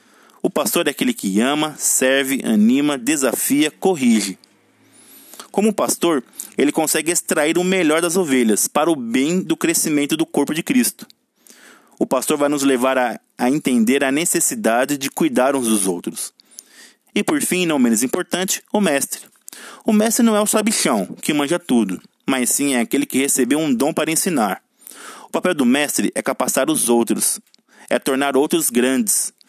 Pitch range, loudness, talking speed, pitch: 135-220 Hz, -18 LUFS, 165 wpm, 160 Hz